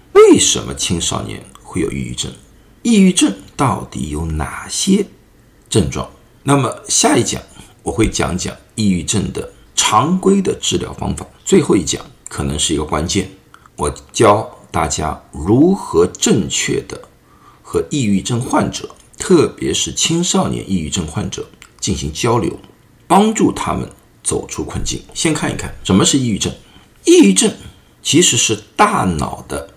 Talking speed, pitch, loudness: 220 characters per minute, 120 Hz, -15 LUFS